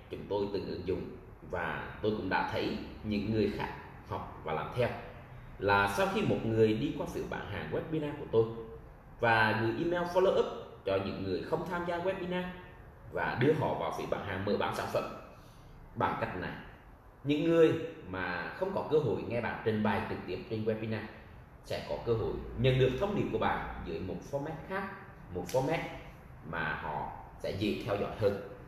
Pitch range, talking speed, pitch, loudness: 110-160 Hz, 195 wpm, 125 Hz, -33 LUFS